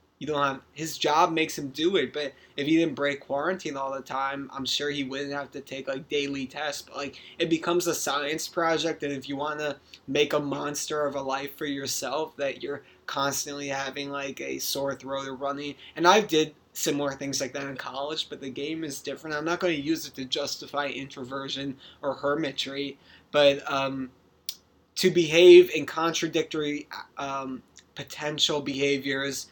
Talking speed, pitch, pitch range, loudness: 185 wpm, 140 Hz, 135-155 Hz, -27 LUFS